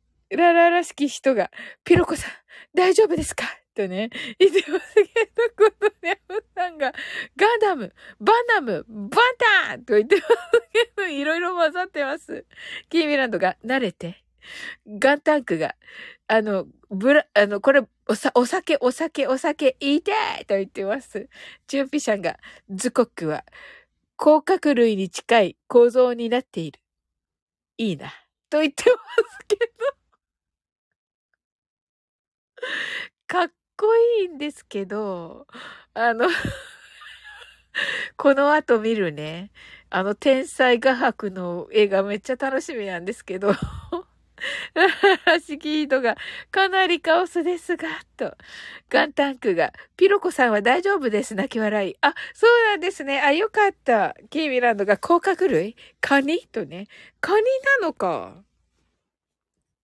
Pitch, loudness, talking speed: 290 Hz, -21 LUFS, 245 characters per minute